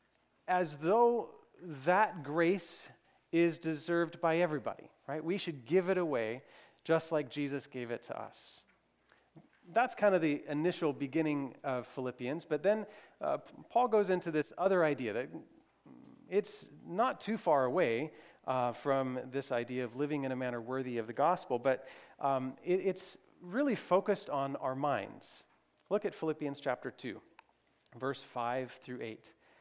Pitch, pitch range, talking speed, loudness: 155 Hz, 130-180 Hz, 150 wpm, -35 LUFS